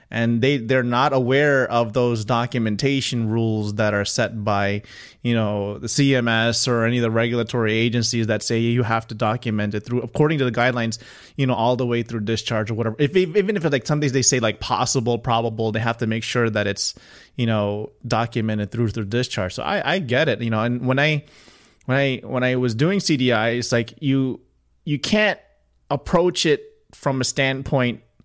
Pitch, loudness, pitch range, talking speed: 120 Hz, -21 LUFS, 115-135 Hz, 205 wpm